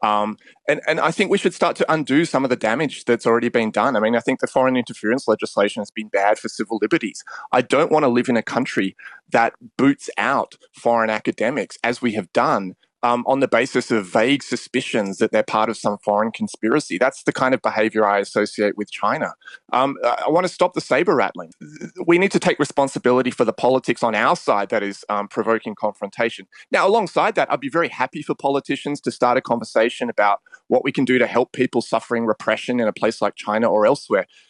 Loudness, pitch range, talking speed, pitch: -20 LUFS, 110-145 Hz, 220 wpm, 120 Hz